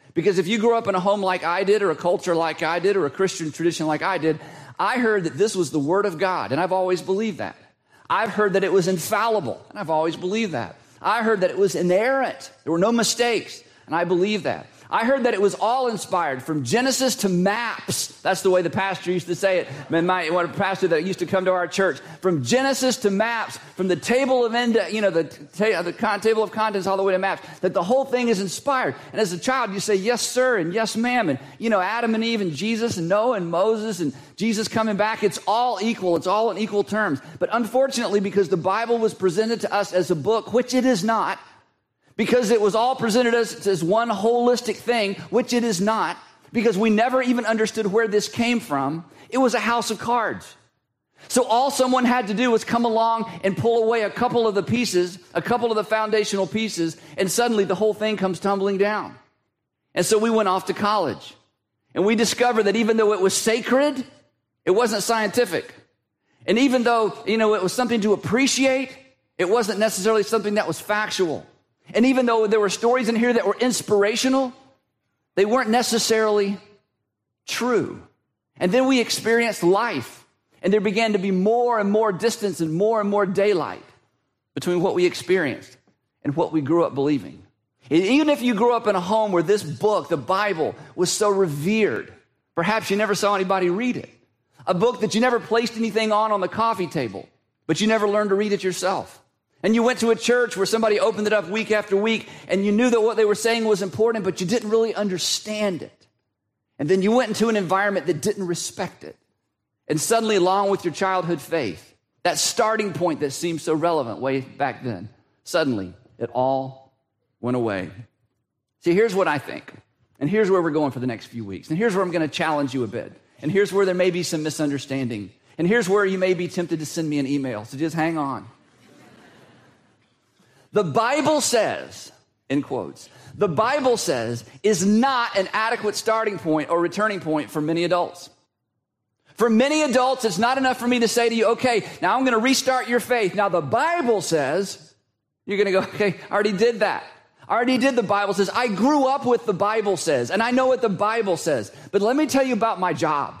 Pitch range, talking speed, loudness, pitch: 175-230 Hz, 215 wpm, -21 LUFS, 205 Hz